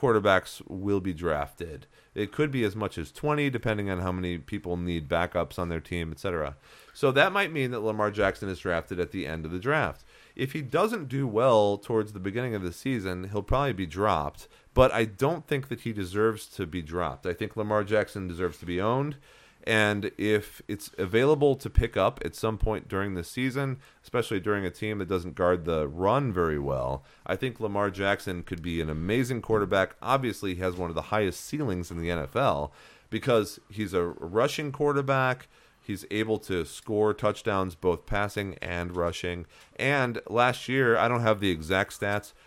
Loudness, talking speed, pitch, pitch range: -28 LUFS, 195 wpm, 100 Hz, 90-115 Hz